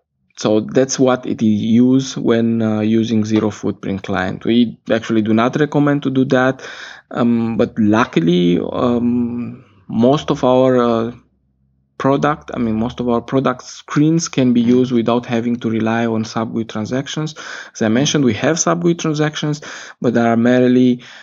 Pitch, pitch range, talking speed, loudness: 120 Hz, 110-130 Hz, 160 wpm, -16 LUFS